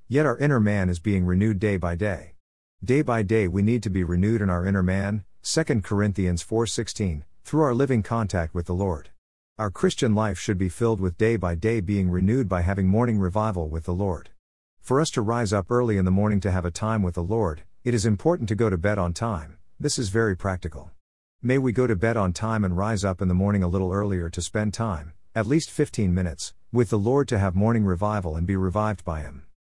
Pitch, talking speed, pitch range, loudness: 100 Hz, 235 wpm, 90-115 Hz, -24 LUFS